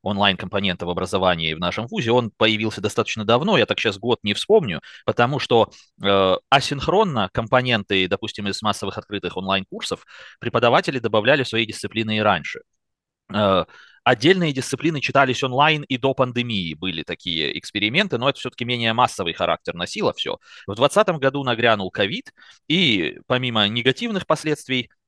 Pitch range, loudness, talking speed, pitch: 100-130 Hz, -20 LUFS, 145 wpm, 115 Hz